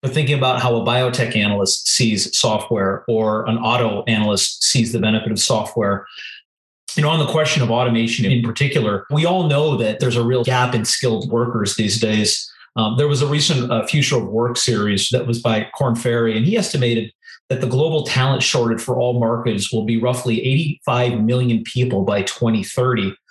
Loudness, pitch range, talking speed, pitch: -18 LUFS, 110-130 Hz, 190 wpm, 120 Hz